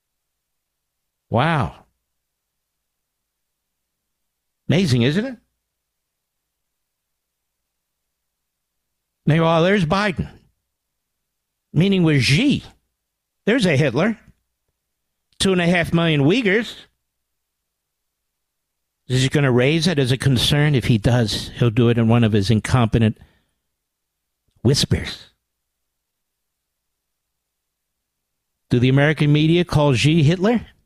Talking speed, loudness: 90 wpm, -18 LUFS